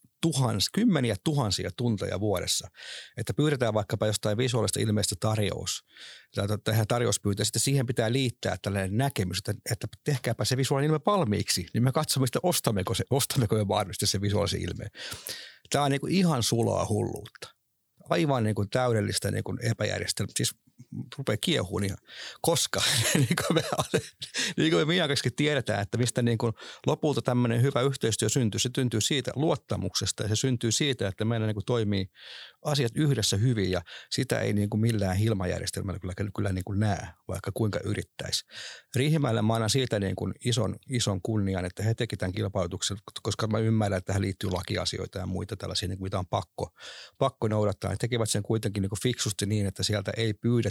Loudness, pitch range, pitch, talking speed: -28 LUFS, 100-125 Hz, 110 Hz, 165 wpm